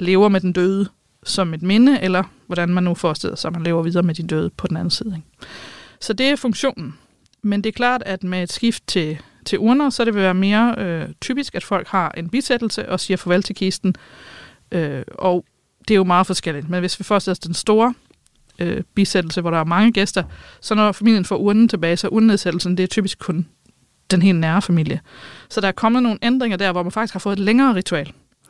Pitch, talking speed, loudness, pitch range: 190 Hz, 225 wpm, -19 LUFS, 175-220 Hz